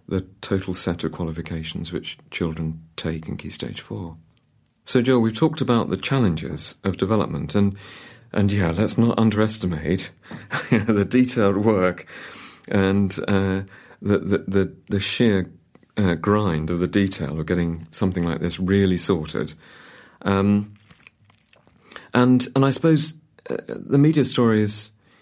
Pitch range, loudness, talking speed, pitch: 90-115 Hz, -22 LUFS, 140 wpm, 100 Hz